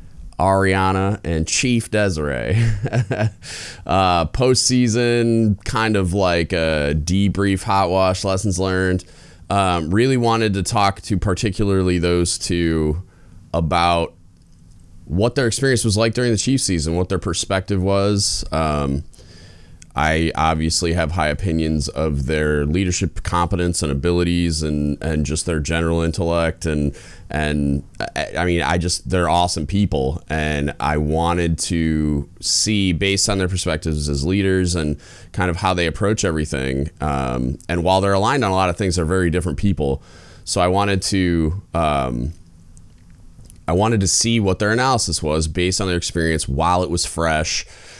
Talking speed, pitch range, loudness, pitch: 150 wpm, 80-100 Hz, -19 LUFS, 90 Hz